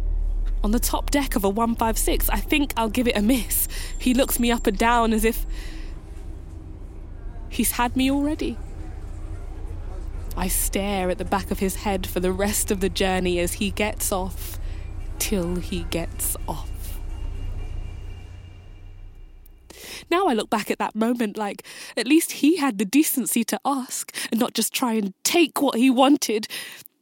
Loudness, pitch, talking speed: -23 LUFS, 200 Hz, 160 wpm